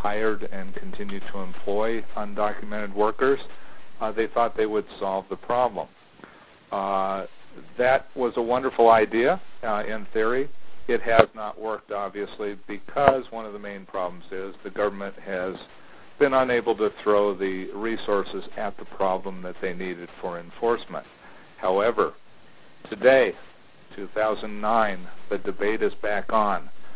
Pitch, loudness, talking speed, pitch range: 105 Hz, -25 LUFS, 135 wpm, 100-115 Hz